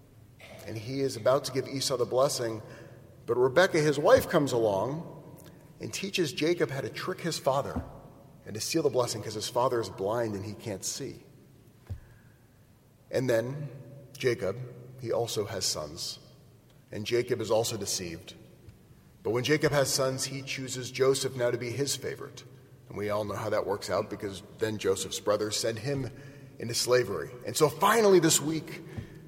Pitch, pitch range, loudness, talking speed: 130 Hz, 115-140 Hz, -29 LUFS, 170 wpm